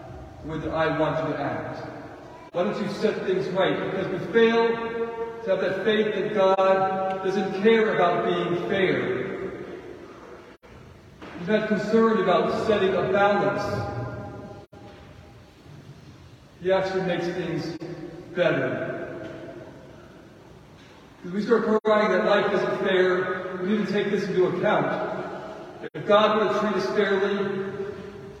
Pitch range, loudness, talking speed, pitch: 175-210 Hz, -24 LUFS, 125 wpm, 195 Hz